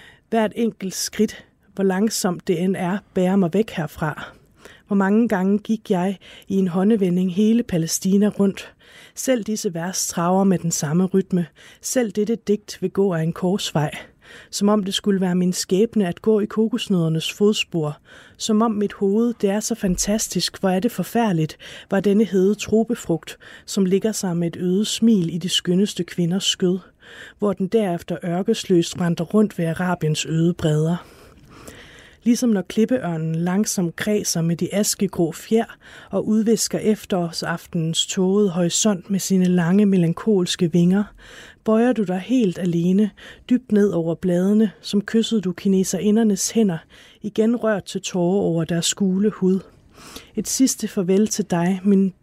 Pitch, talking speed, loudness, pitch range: 195 Hz, 155 wpm, -21 LUFS, 180-215 Hz